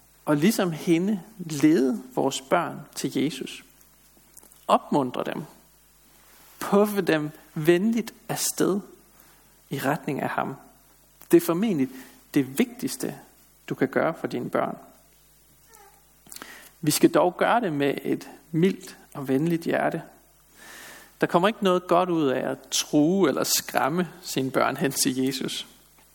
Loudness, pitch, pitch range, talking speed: -25 LUFS, 165 Hz, 140-185 Hz, 130 wpm